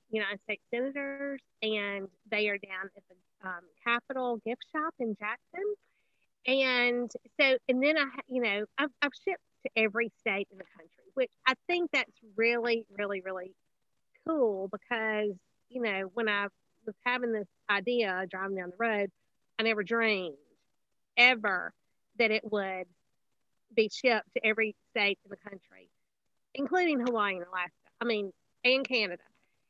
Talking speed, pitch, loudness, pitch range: 150 wpm, 225 Hz, -31 LUFS, 200-255 Hz